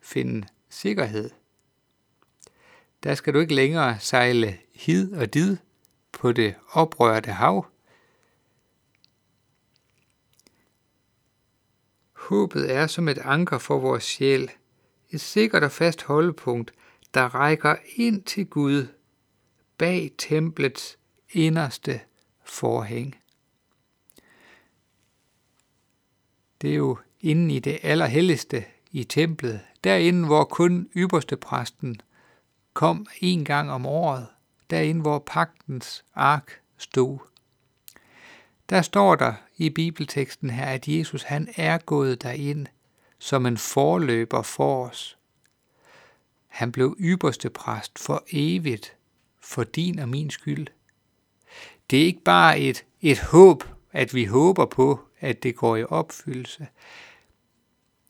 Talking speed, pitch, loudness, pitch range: 105 wpm, 135 Hz, -23 LUFS, 120-160 Hz